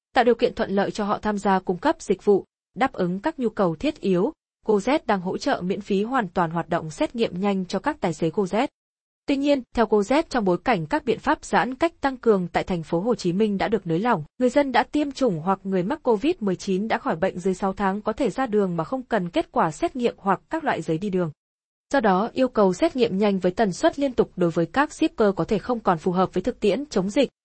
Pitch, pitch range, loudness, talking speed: 210 Hz, 190-260 Hz, -23 LUFS, 265 wpm